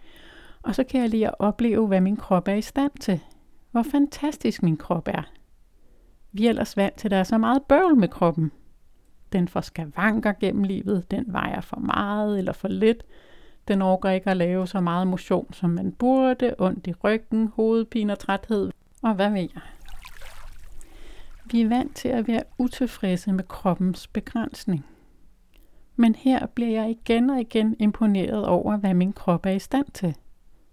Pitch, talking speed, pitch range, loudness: 210 Hz, 180 wpm, 190-235 Hz, -24 LUFS